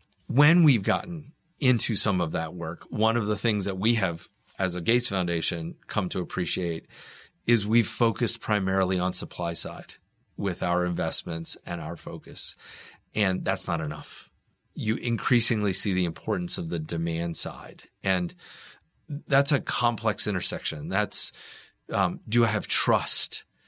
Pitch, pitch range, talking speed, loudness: 105 Hz, 90-120 Hz, 150 wpm, -26 LUFS